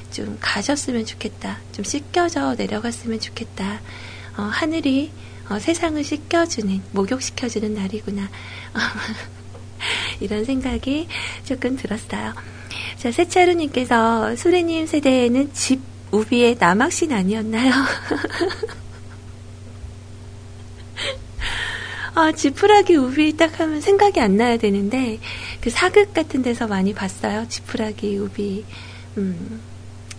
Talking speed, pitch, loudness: 235 characters per minute, 215 Hz, -20 LUFS